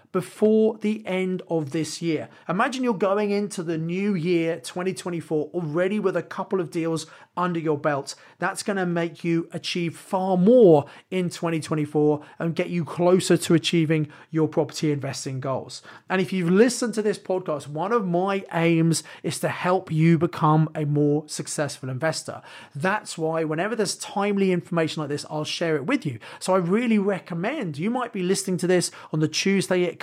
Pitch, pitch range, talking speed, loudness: 170 Hz, 160-190 Hz, 180 wpm, -24 LUFS